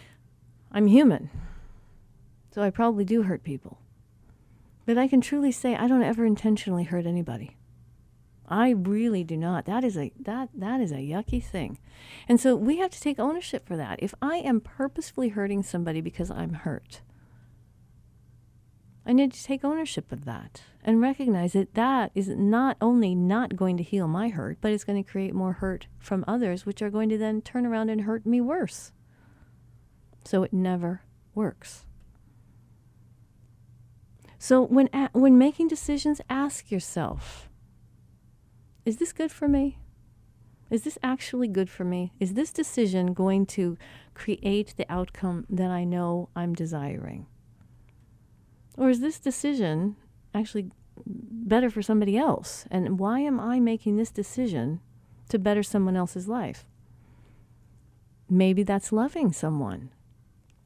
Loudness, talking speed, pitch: -26 LUFS, 150 wpm, 195 Hz